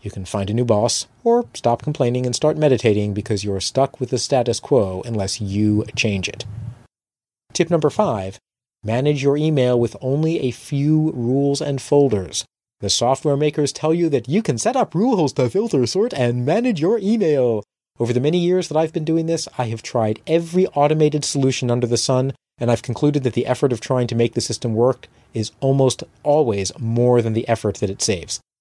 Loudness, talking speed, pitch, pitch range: -19 LUFS, 200 wpm, 125 Hz, 115-150 Hz